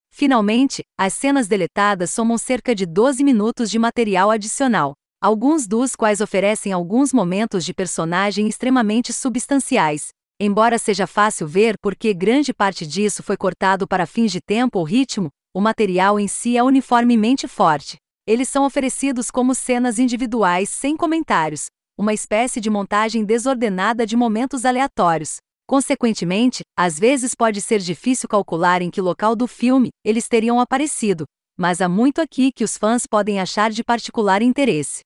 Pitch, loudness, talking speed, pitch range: 220 Hz, -18 LUFS, 150 wpm, 195-250 Hz